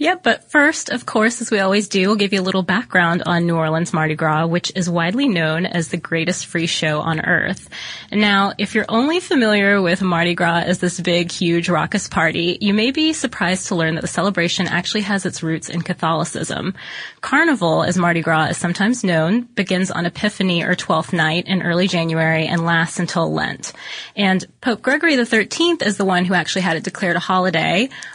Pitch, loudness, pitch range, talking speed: 180 Hz, -18 LUFS, 170-210 Hz, 205 wpm